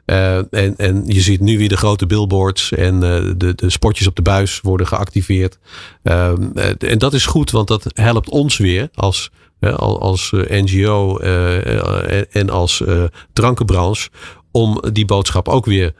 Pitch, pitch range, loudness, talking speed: 95 Hz, 90-105 Hz, -15 LUFS, 165 wpm